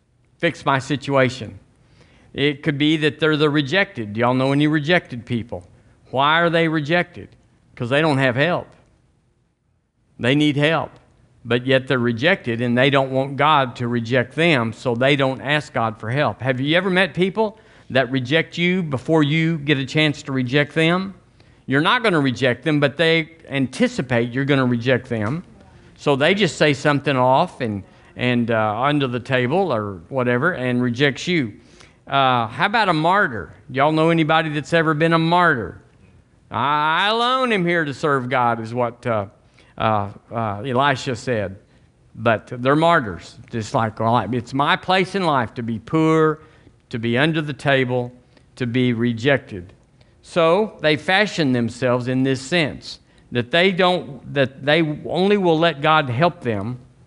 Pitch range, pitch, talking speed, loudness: 120-160 Hz, 135 Hz, 170 wpm, -19 LUFS